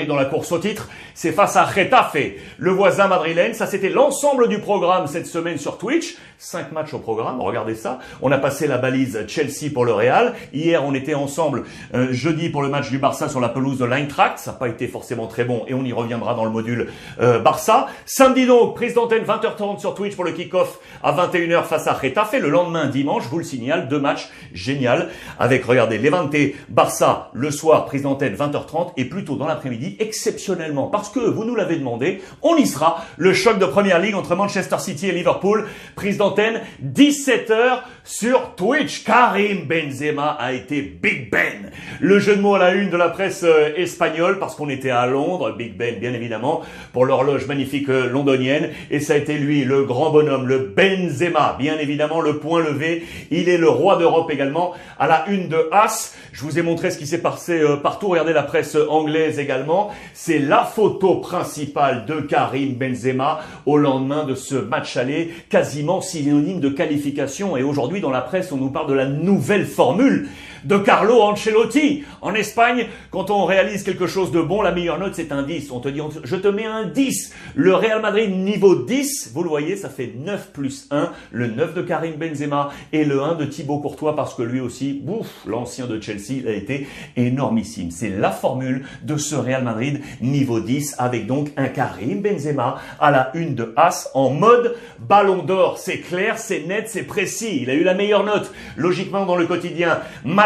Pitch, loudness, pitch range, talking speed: 160 Hz, -19 LUFS, 140-195 Hz, 200 wpm